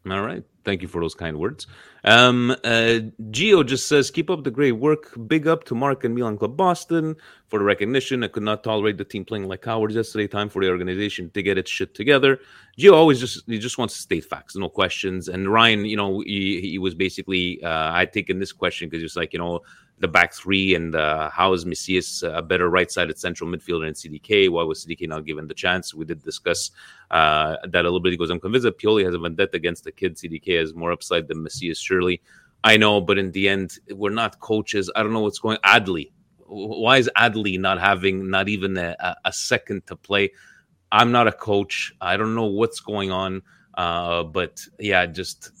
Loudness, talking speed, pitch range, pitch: -21 LUFS, 220 wpm, 90-115 Hz, 100 Hz